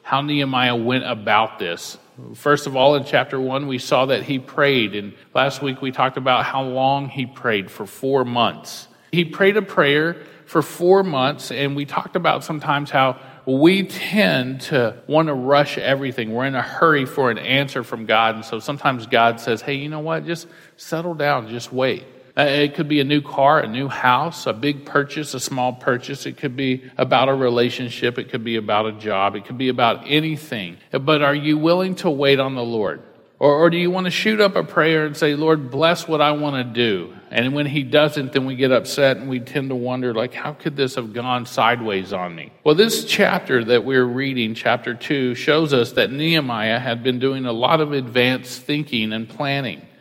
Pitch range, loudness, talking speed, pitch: 125-150 Hz, -19 LUFS, 210 wpm, 135 Hz